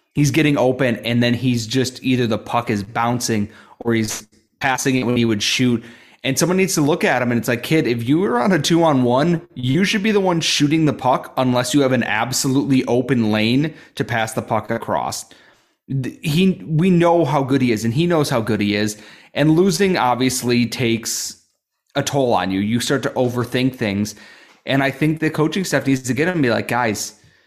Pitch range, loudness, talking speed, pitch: 115-150 Hz, -18 LUFS, 220 wpm, 130 Hz